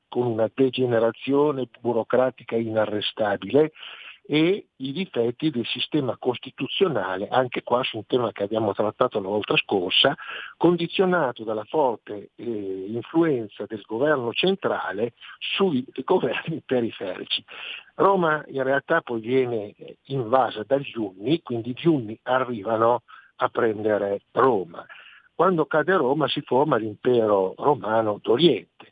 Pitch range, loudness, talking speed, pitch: 110-145 Hz, -24 LUFS, 115 wpm, 125 Hz